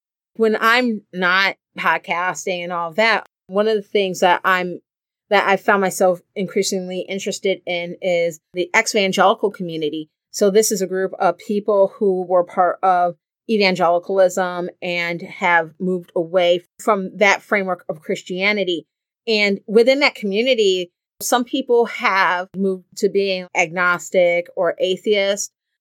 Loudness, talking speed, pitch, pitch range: -18 LUFS, 140 wpm, 190 Hz, 180-205 Hz